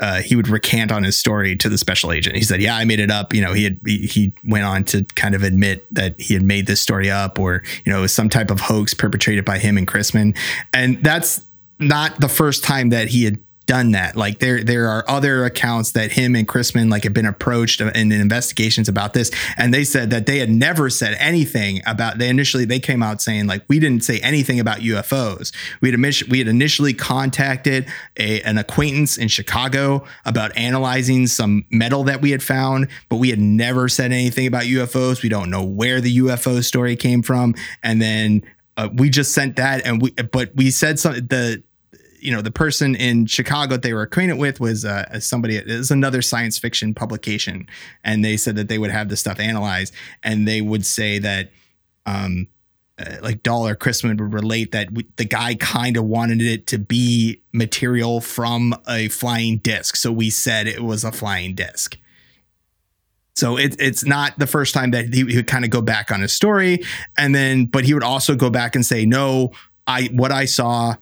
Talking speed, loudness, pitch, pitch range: 210 wpm, -18 LUFS, 115 Hz, 105-130 Hz